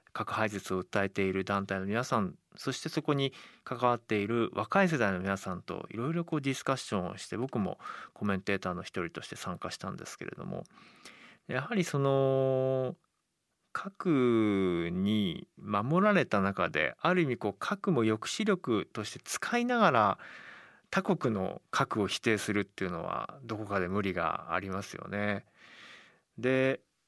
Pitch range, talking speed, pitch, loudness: 100-150 Hz, 305 characters per minute, 115 Hz, -32 LUFS